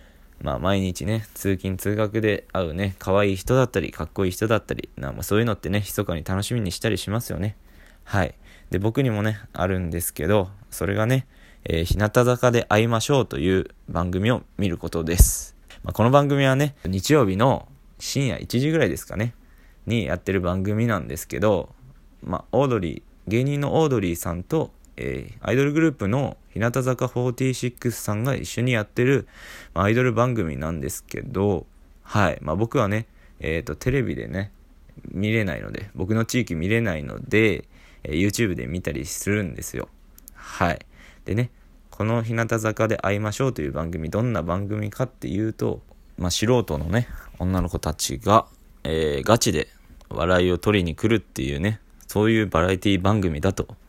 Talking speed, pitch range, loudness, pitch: 350 characters per minute, 85-115 Hz, -24 LUFS, 100 Hz